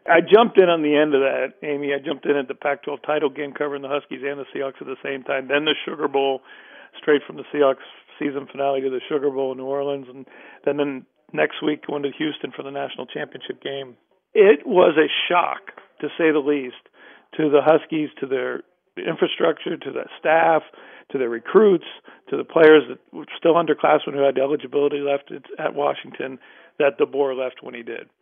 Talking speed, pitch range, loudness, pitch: 210 wpm, 135-150 Hz, -21 LUFS, 145 Hz